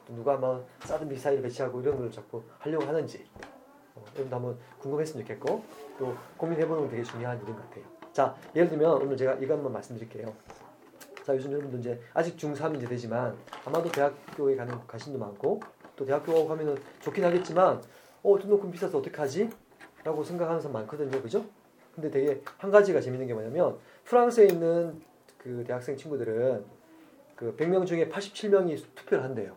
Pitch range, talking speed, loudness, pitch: 130-175 Hz, 375 characters per minute, -29 LUFS, 150 Hz